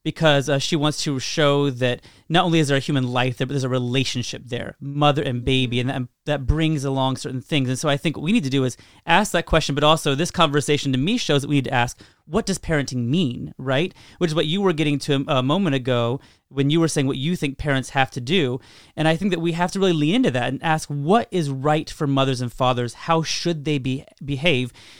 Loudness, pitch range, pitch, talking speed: -21 LUFS, 130-160 Hz, 145 Hz, 260 wpm